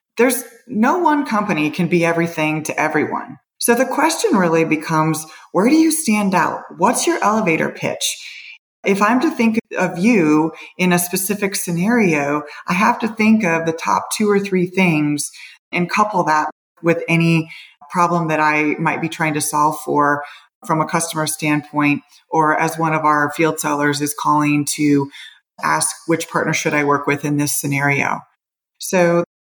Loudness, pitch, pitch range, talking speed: -17 LUFS, 165 Hz, 150-205 Hz, 170 wpm